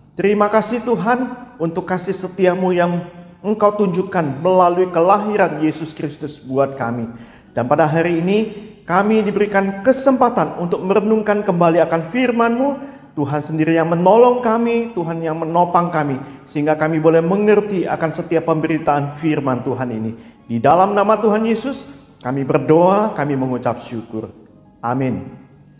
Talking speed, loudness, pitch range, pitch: 135 wpm, -17 LUFS, 155-210 Hz, 175 Hz